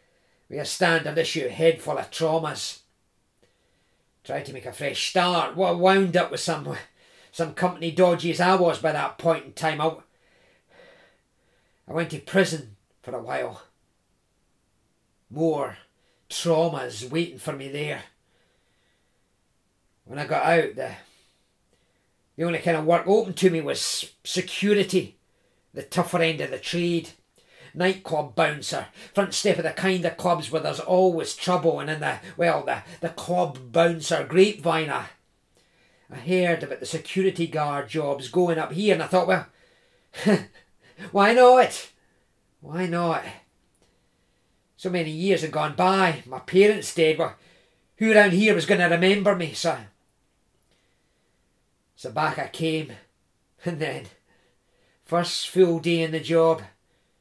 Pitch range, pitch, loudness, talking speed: 155-185 Hz, 170 Hz, -23 LUFS, 145 wpm